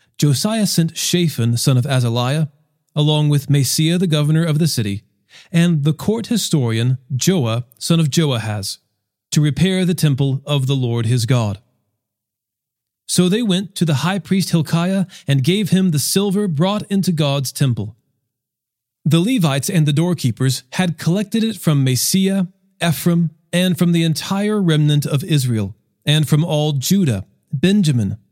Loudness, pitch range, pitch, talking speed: -17 LUFS, 125-175 Hz, 155 Hz, 150 wpm